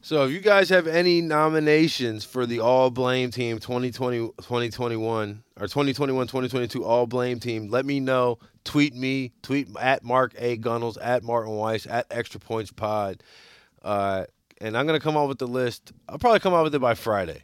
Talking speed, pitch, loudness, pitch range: 190 wpm, 125 Hz, -24 LUFS, 115-140 Hz